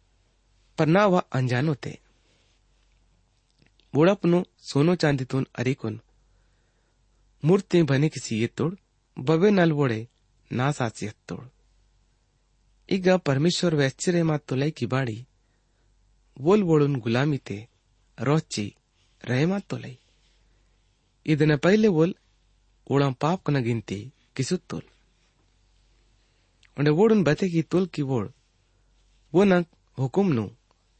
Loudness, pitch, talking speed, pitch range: -24 LUFS, 125 Hz, 110 wpm, 105-155 Hz